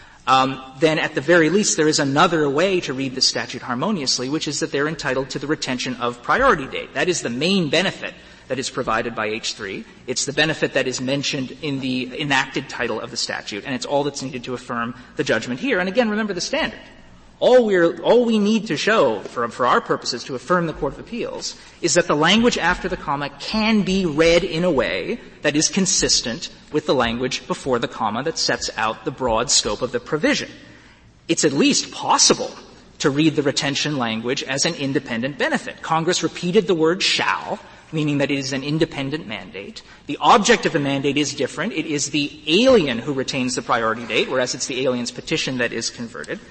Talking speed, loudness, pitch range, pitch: 210 wpm, -20 LUFS, 130-170 Hz, 150 Hz